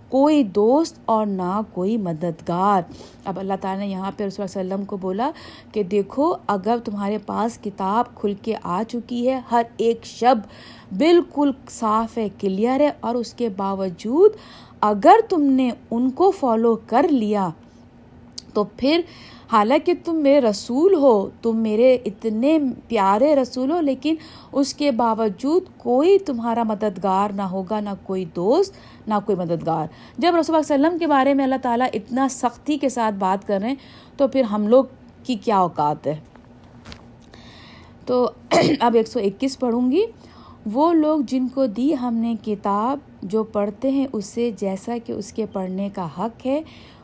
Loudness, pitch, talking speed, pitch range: -21 LUFS, 230 Hz, 165 wpm, 200-270 Hz